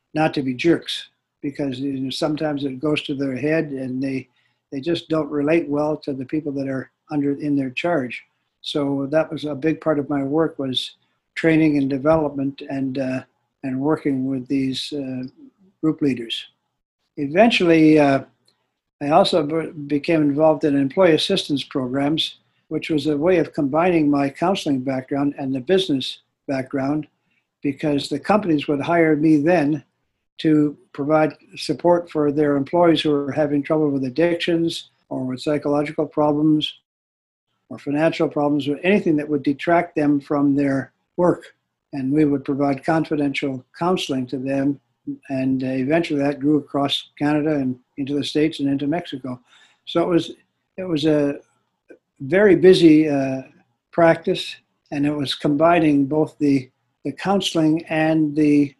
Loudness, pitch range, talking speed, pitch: -20 LUFS, 140-155 Hz, 155 wpm, 145 Hz